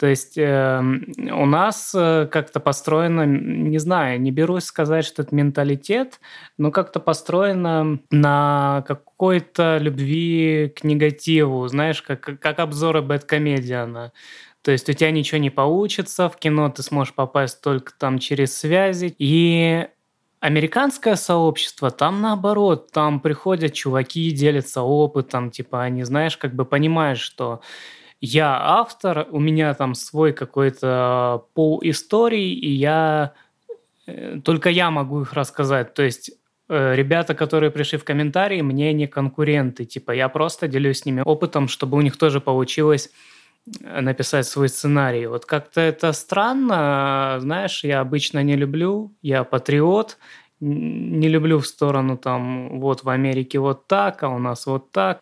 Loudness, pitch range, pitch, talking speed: -20 LUFS, 135-160 Hz, 150 Hz, 140 wpm